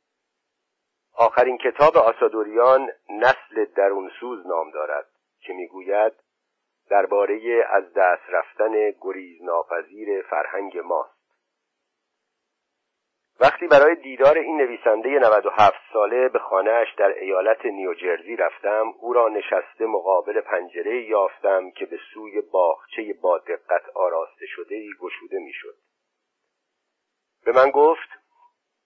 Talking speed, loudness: 105 wpm, -21 LUFS